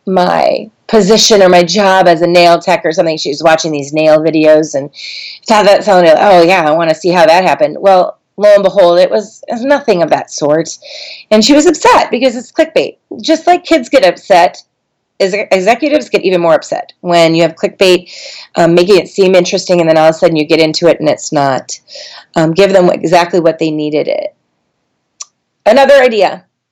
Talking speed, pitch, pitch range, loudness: 200 wpm, 190 Hz, 165-235 Hz, -9 LUFS